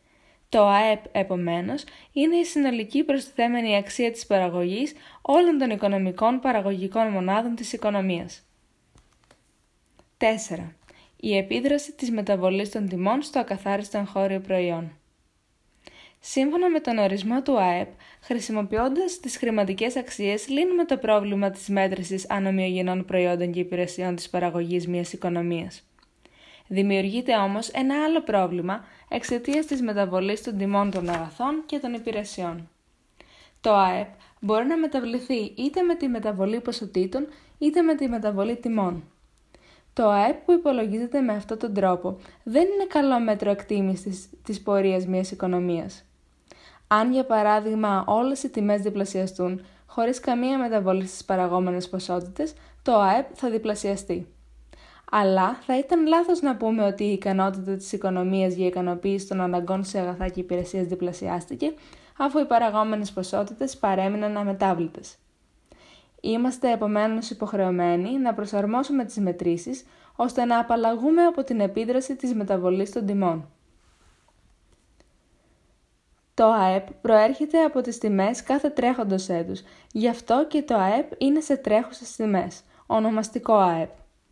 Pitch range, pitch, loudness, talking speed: 190-250 Hz, 210 Hz, -24 LUFS, 125 wpm